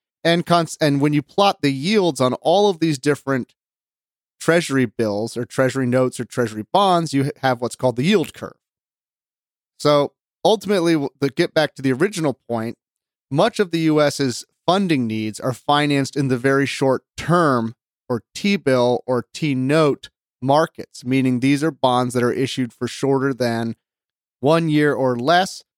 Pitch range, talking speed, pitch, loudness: 125-160 Hz, 170 wpm, 140 Hz, -19 LUFS